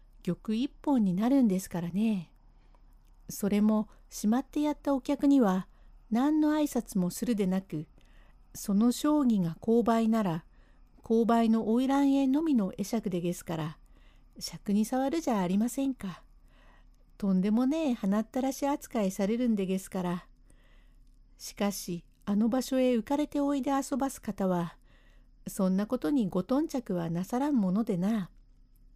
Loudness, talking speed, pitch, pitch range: -29 LUFS, 275 characters per minute, 215 Hz, 185-260 Hz